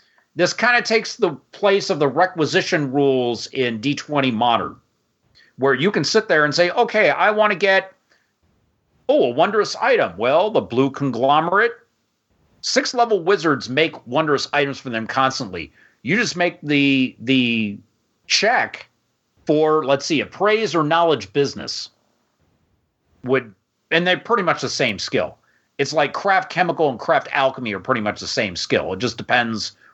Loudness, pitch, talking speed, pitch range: -19 LUFS, 150 Hz, 160 wpm, 130-190 Hz